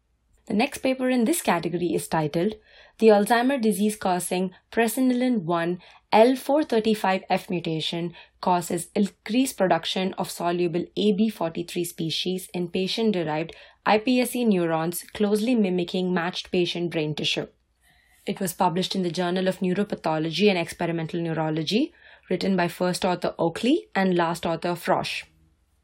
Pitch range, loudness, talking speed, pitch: 170-215 Hz, -24 LUFS, 120 wpm, 185 Hz